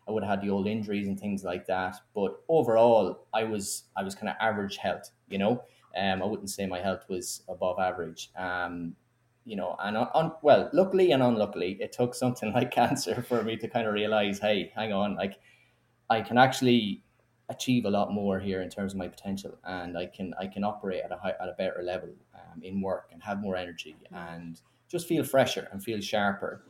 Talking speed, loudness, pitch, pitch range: 220 wpm, -29 LUFS, 100 Hz, 95-115 Hz